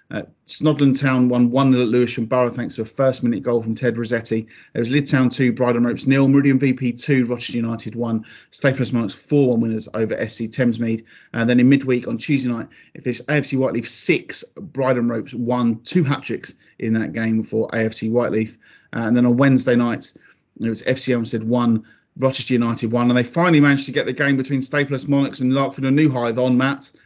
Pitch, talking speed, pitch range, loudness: 125 Hz, 210 wpm, 115-135 Hz, -19 LUFS